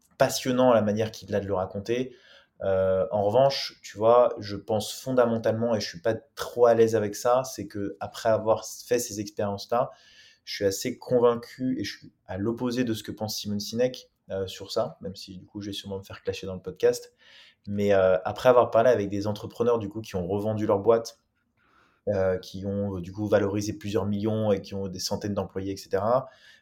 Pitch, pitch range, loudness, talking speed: 105 Hz, 100-120 Hz, -26 LUFS, 215 wpm